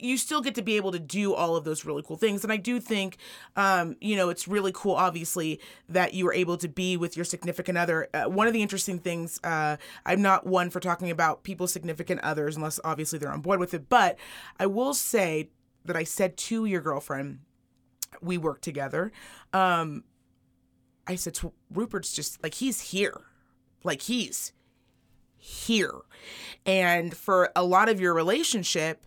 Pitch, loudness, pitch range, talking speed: 180 Hz, -27 LUFS, 165-200 Hz, 185 wpm